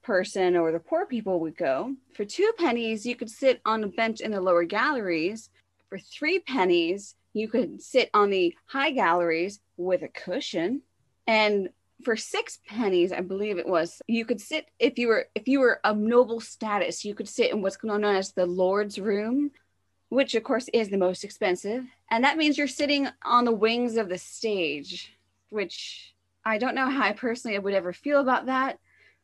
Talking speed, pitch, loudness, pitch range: 190 wpm, 225 Hz, -26 LUFS, 195-260 Hz